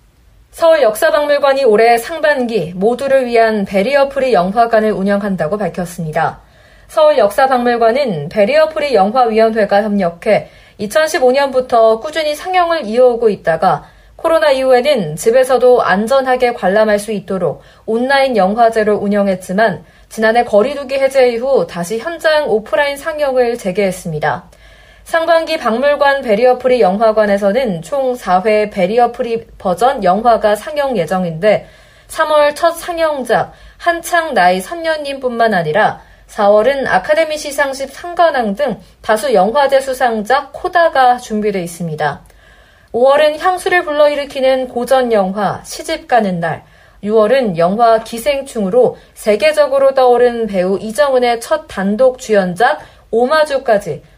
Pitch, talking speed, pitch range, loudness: 245 Hz, 305 characters per minute, 210-285 Hz, -13 LUFS